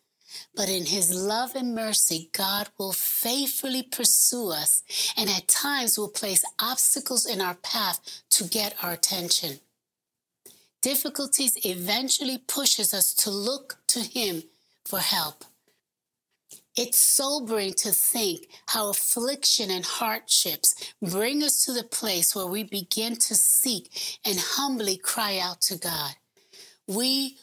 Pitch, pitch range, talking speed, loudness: 220 Hz, 195-260 Hz, 130 wpm, -23 LUFS